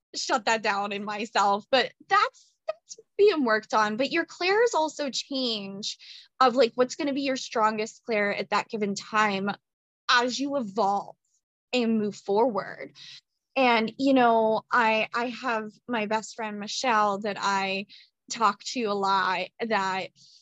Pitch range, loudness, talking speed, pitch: 205-265 Hz, -26 LUFS, 155 wpm, 225 Hz